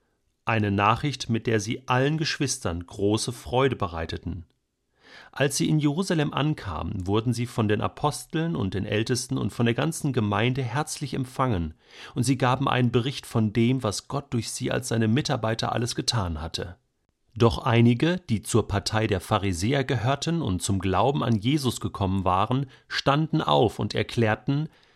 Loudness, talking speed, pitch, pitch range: -25 LUFS, 160 wpm, 120 Hz, 105-135 Hz